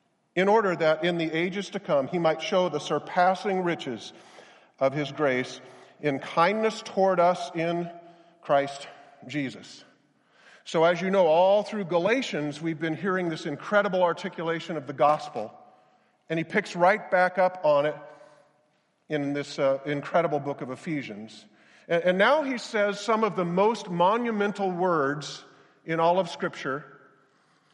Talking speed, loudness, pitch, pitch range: 150 wpm, -26 LUFS, 170 Hz, 150-185 Hz